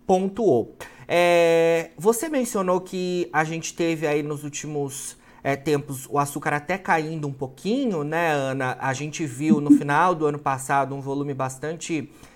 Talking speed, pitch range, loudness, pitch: 155 wpm, 140-170 Hz, -23 LUFS, 150 Hz